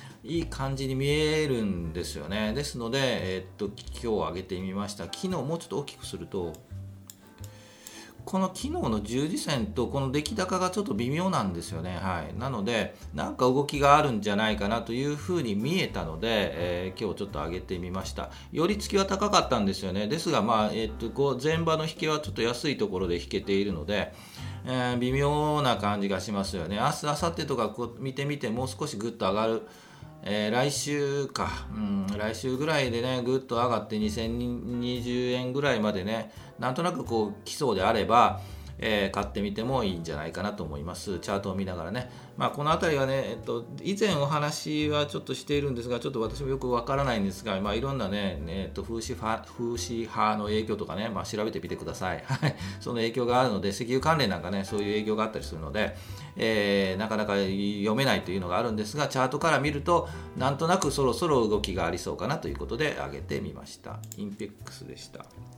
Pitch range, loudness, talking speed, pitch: 100-135 Hz, -29 LUFS, 415 characters per minute, 110 Hz